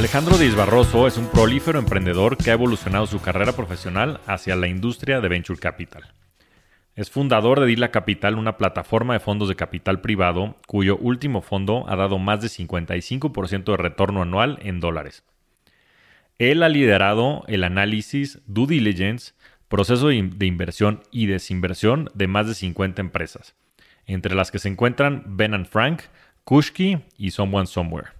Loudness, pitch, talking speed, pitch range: -21 LUFS, 105 Hz, 155 wpm, 95-120 Hz